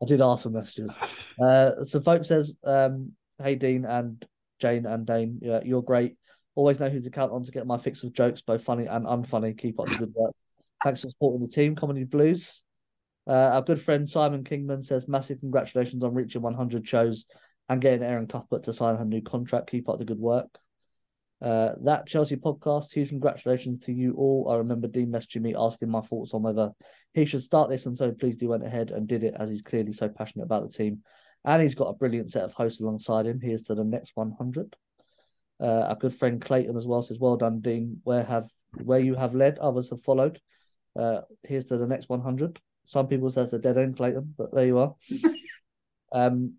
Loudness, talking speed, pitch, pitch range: -27 LUFS, 215 wpm, 125 Hz, 115-135 Hz